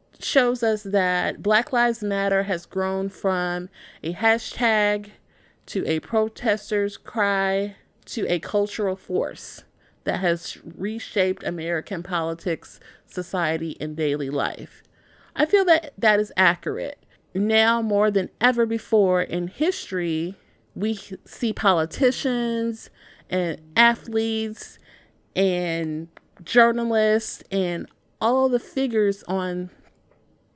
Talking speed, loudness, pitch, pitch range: 105 wpm, -23 LUFS, 200 Hz, 175-225 Hz